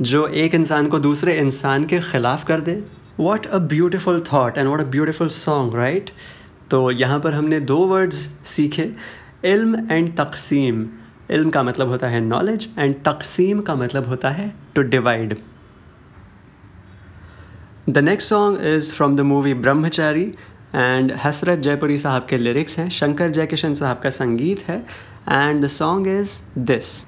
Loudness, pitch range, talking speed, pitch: -19 LUFS, 130-165 Hz, 155 wpm, 145 Hz